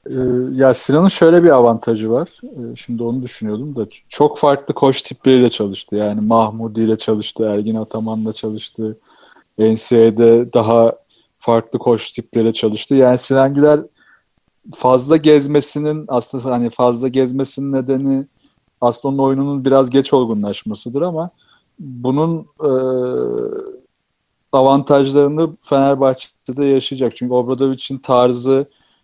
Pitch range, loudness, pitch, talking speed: 115-140 Hz, -15 LUFS, 130 Hz, 110 wpm